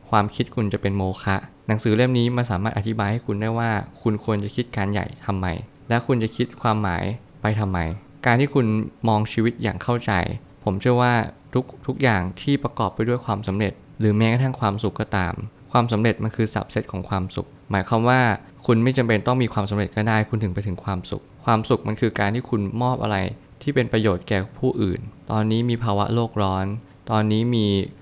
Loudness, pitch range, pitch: -23 LUFS, 100-120 Hz, 110 Hz